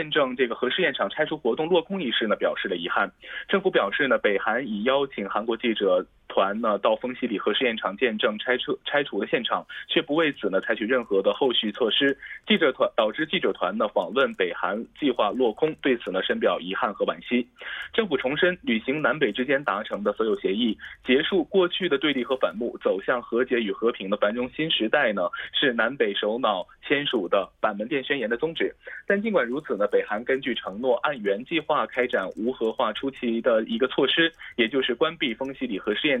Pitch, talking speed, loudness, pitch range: 135 Hz, 320 characters per minute, -25 LUFS, 115-180 Hz